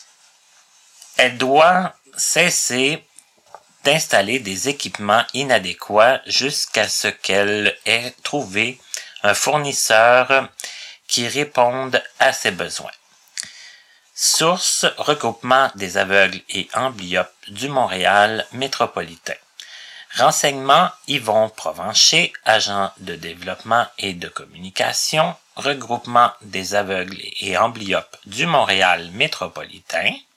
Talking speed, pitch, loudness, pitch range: 90 wpm, 120 Hz, -17 LUFS, 100-135 Hz